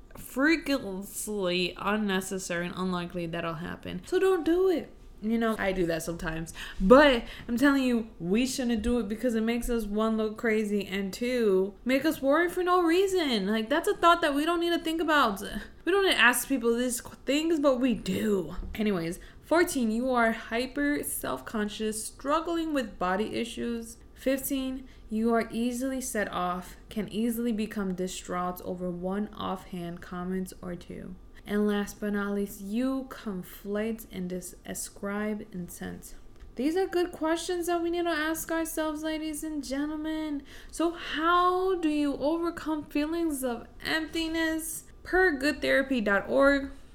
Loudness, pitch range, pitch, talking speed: -28 LUFS, 200-310 Hz, 235 Hz, 155 wpm